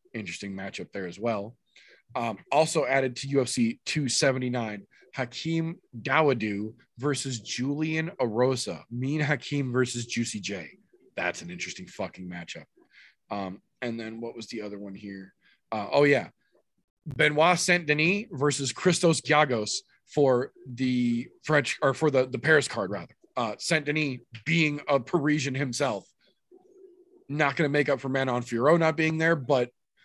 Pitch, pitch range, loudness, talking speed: 135 Hz, 120-155 Hz, -27 LUFS, 145 wpm